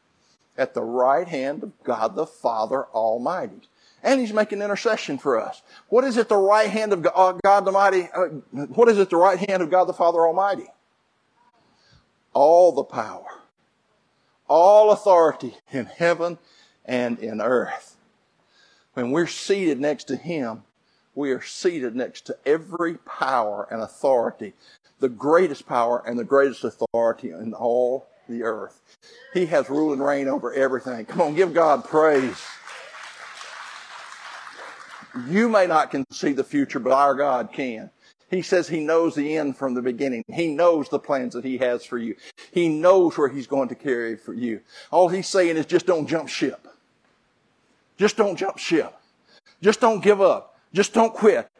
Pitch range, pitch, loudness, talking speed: 135-205 Hz, 170 Hz, -22 LUFS, 165 wpm